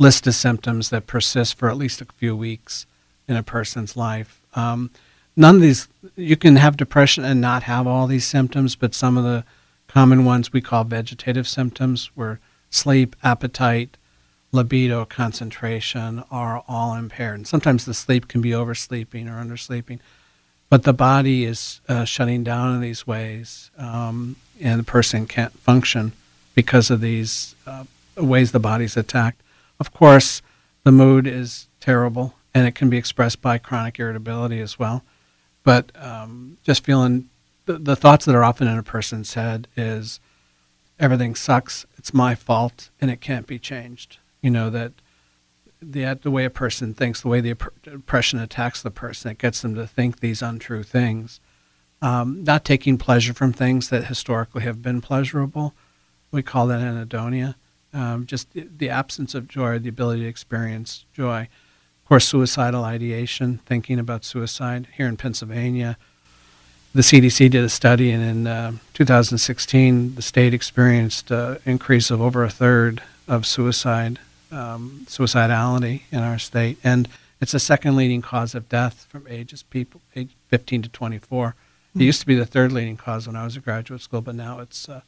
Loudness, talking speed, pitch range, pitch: -19 LUFS, 170 wpm, 115-130 Hz, 120 Hz